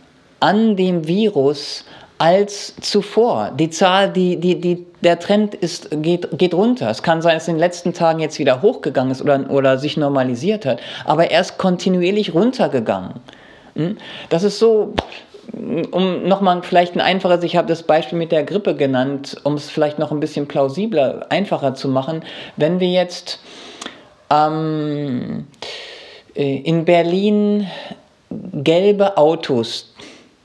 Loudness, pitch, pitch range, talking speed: -17 LUFS, 170 Hz, 150-195 Hz, 145 wpm